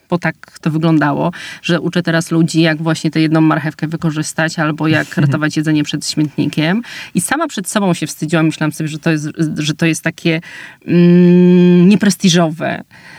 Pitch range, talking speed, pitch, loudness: 155-175 Hz, 170 wpm, 165 Hz, -14 LUFS